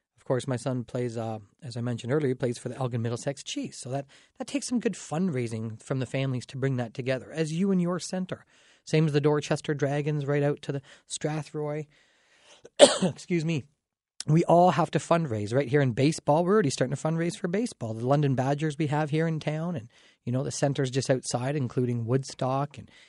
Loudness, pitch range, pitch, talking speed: -28 LUFS, 130-160 Hz, 145 Hz, 215 wpm